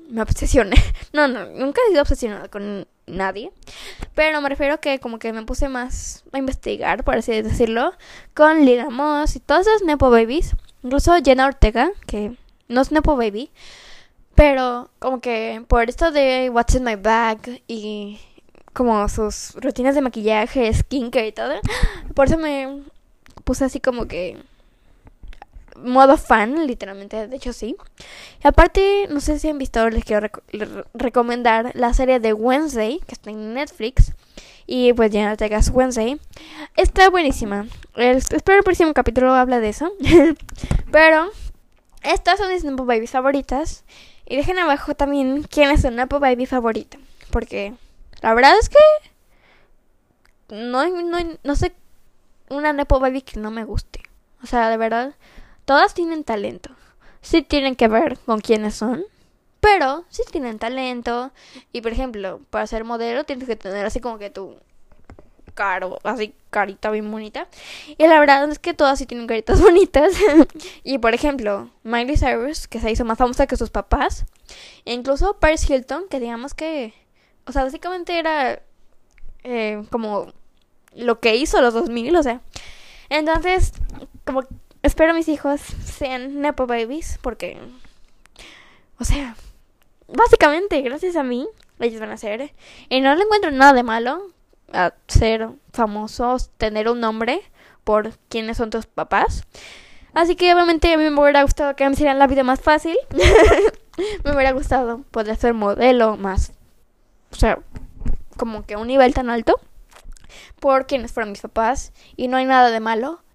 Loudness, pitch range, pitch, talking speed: -18 LUFS, 230-300 Hz, 260 Hz, 160 wpm